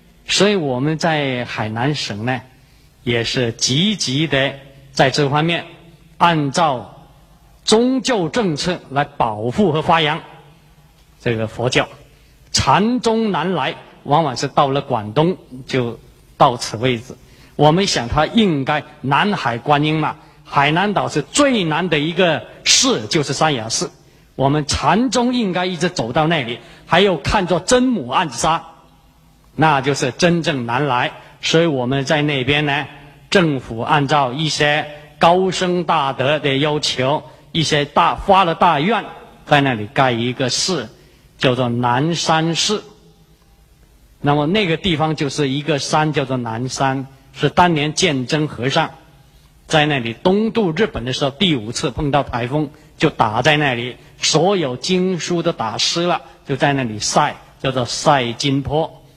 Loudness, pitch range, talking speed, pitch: -17 LUFS, 135-170 Hz, 210 characters per minute, 150 Hz